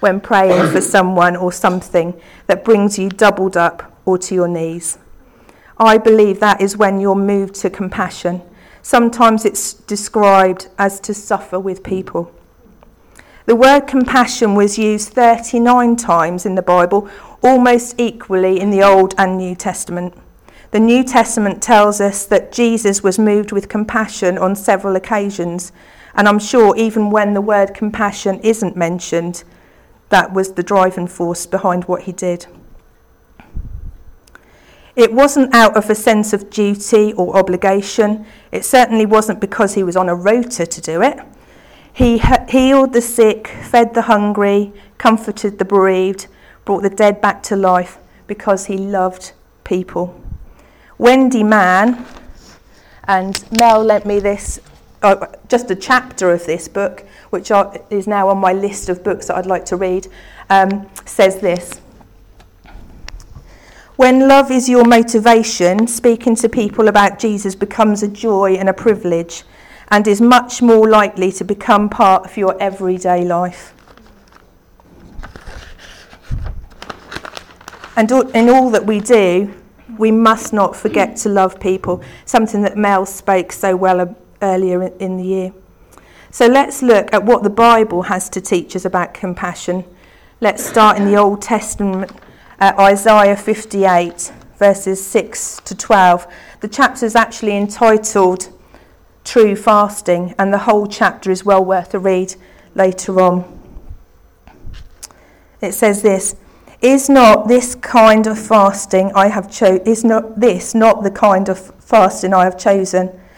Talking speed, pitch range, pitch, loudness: 145 wpm, 185-220 Hz, 200 Hz, -13 LUFS